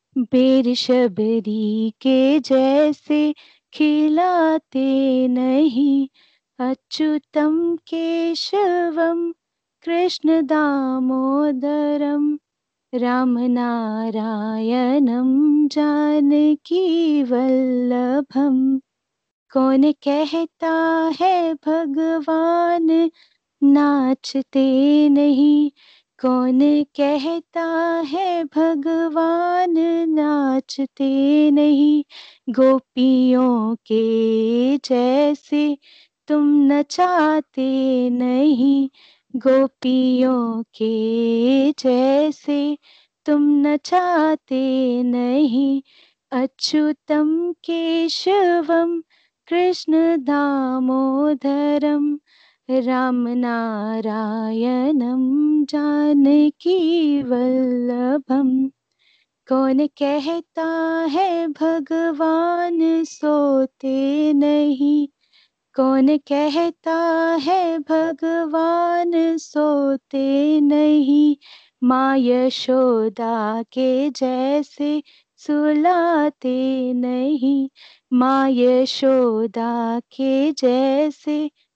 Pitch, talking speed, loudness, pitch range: 290 Hz, 50 wpm, -18 LUFS, 260-320 Hz